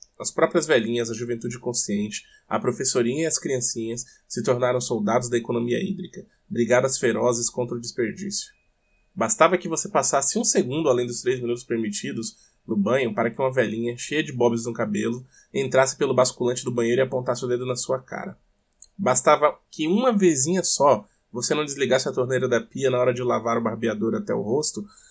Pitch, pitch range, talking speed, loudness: 125 Hz, 120-155 Hz, 185 wpm, -23 LUFS